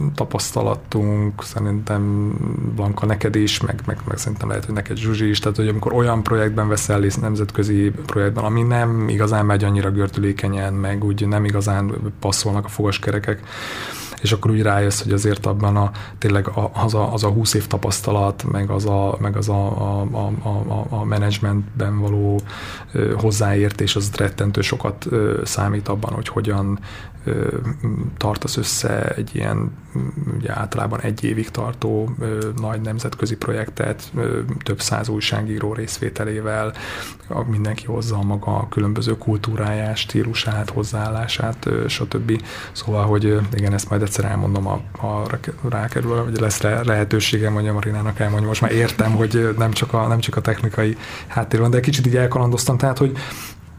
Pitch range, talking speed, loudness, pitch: 105-115 Hz, 150 wpm, -20 LUFS, 105 Hz